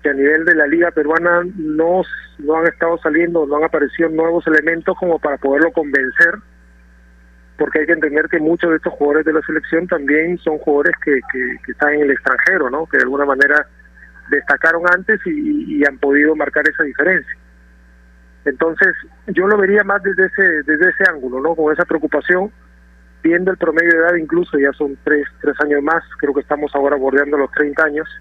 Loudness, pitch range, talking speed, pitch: -15 LUFS, 145-170 Hz, 195 wpm, 155 Hz